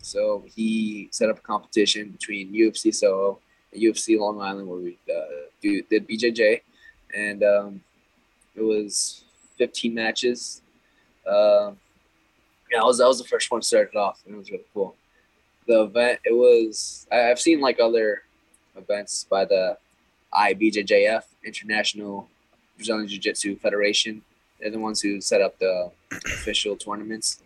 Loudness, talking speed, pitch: -23 LUFS, 140 wpm, 110 Hz